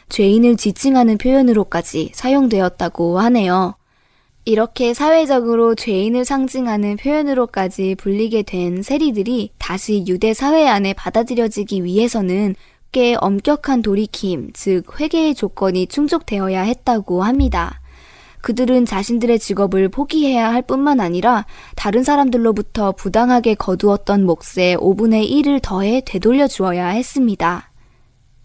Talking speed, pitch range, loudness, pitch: 310 characters per minute, 190-250 Hz, -16 LUFS, 220 Hz